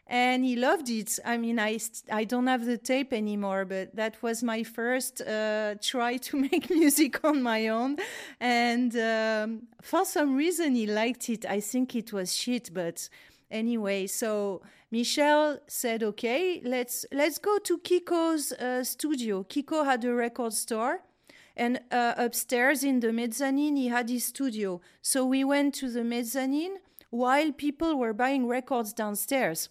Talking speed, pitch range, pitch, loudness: 160 wpm, 225-275 Hz, 245 Hz, -28 LUFS